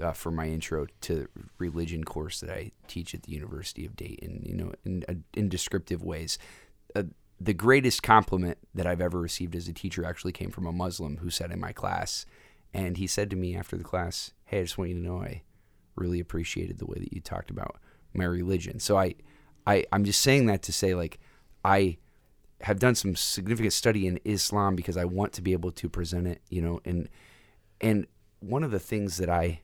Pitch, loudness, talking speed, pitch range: 90 Hz, -29 LUFS, 215 wpm, 85-100 Hz